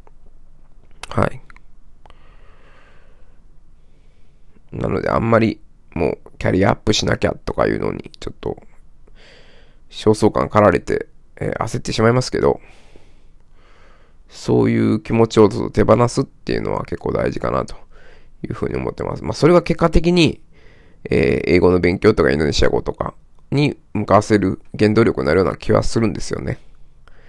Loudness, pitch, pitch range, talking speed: -18 LUFS, 95 Hz, 80-115 Hz, 300 characters per minute